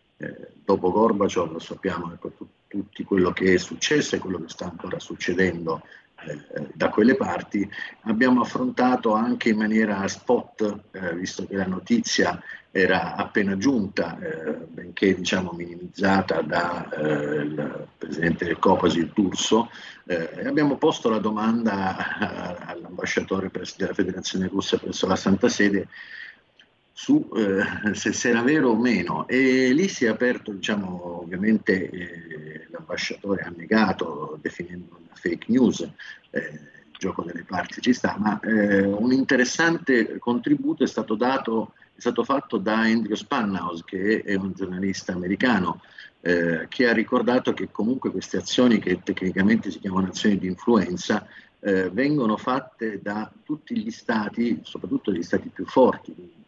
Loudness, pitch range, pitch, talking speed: -24 LUFS, 95-125 Hz, 105 Hz, 145 wpm